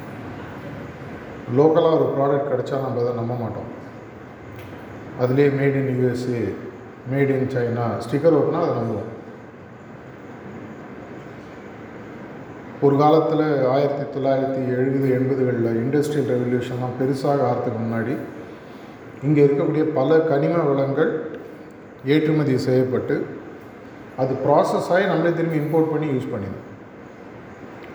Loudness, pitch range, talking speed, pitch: -21 LUFS, 125-150 Hz, 100 wpm, 135 Hz